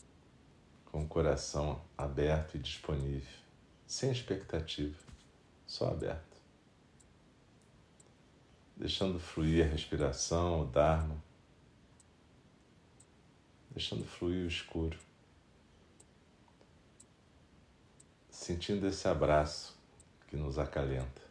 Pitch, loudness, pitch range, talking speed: 80 Hz, -36 LUFS, 75-85 Hz, 75 wpm